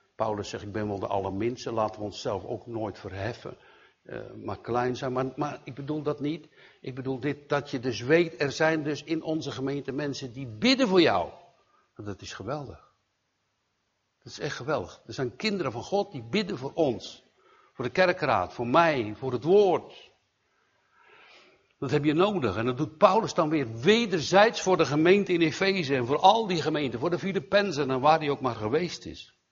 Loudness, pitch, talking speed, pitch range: -27 LUFS, 145 Hz, 195 wpm, 125-175 Hz